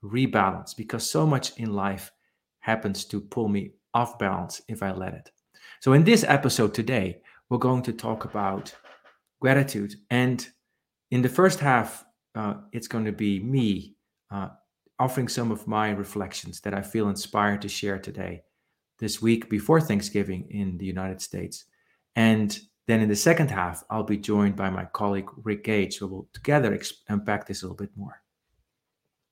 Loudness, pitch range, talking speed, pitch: -26 LUFS, 100-120 Hz, 170 wpm, 105 Hz